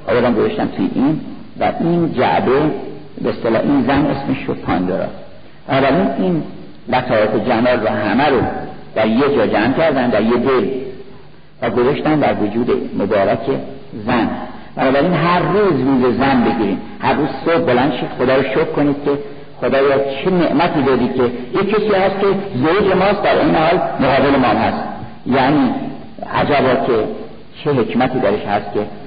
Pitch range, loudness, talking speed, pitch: 125-175 Hz, -16 LUFS, 155 wpm, 140 Hz